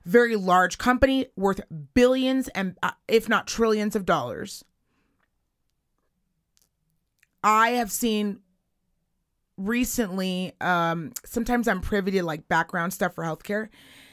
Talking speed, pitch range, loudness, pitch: 110 wpm, 180-235 Hz, -24 LUFS, 205 Hz